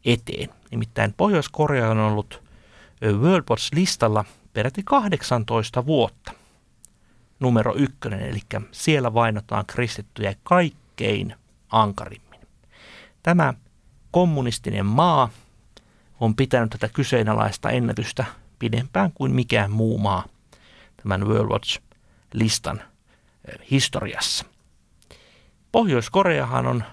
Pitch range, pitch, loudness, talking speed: 105-135 Hz, 115 Hz, -22 LUFS, 80 wpm